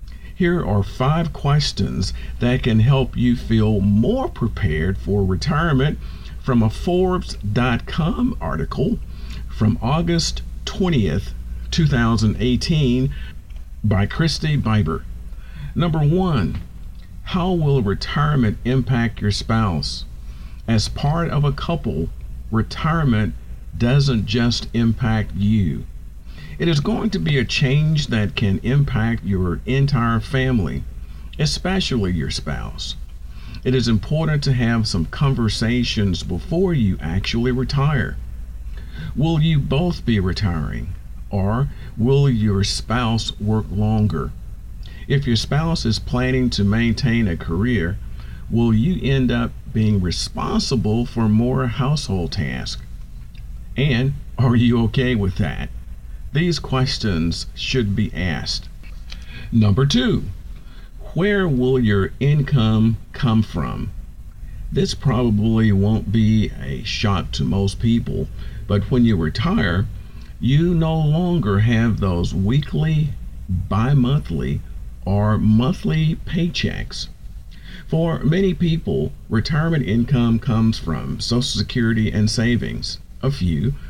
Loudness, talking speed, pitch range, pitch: -20 LUFS, 110 wpm, 95-135 Hz, 115 Hz